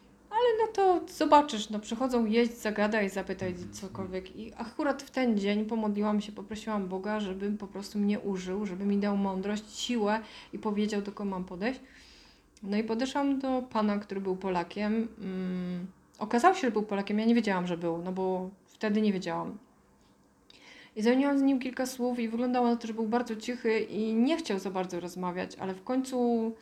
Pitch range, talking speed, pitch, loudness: 195-240 Hz, 185 wpm, 215 Hz, -30 LUFS